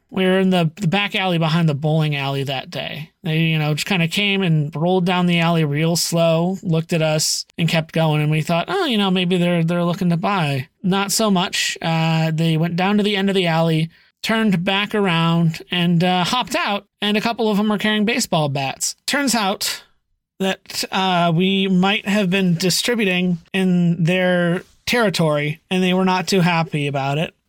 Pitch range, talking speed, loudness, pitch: 165-195 Hz, 205 wpm, -18 LUFS, 180 Hz